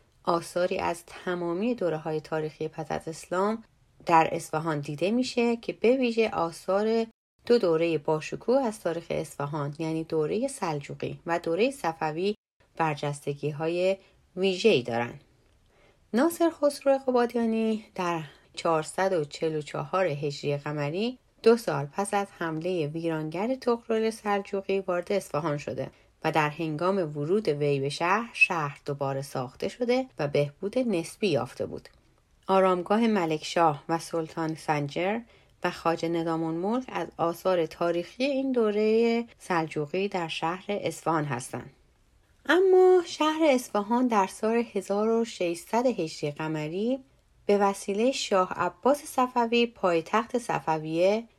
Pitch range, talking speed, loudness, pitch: 160-225 Hz, 115 wpm, -28 LUFS, 175 Hz